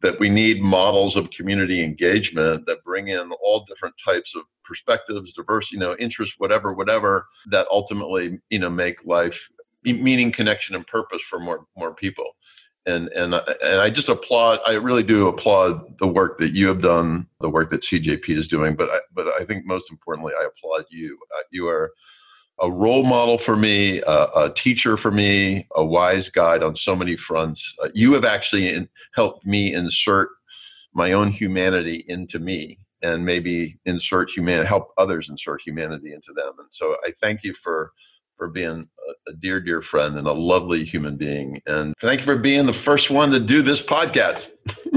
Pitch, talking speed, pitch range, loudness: 100 Hz, 185 wpm, 85-140 Hz, -20 LUFS